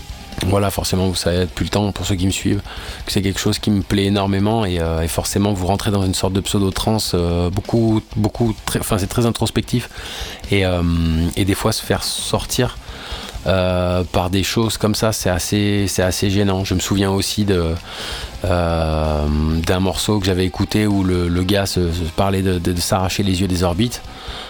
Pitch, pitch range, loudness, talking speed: 95 Hz, 90-105 Hz, -19 LUFS, 205 wpm